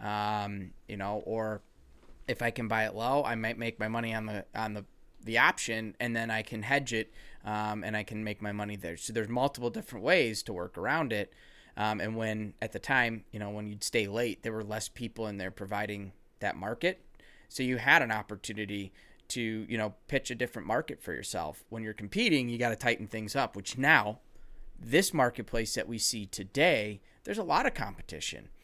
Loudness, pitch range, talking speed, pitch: -32 LUFS, 105-115 Hz, 210 wpm, 110 Hz